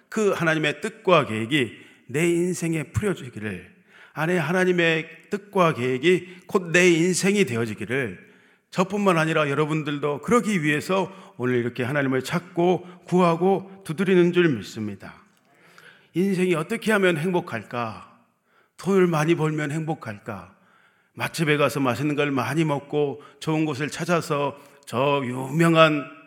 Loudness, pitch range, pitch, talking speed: -23 LUFS, 140-180 Hz, 160 Hz, 290 characters per minute